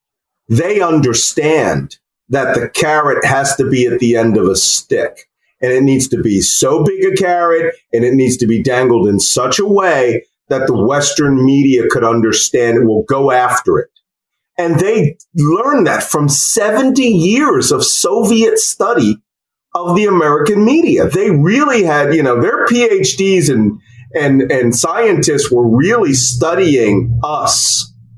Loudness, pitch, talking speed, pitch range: -12 LUFS, 145 Hz, 155 wpm, 125-195 Hz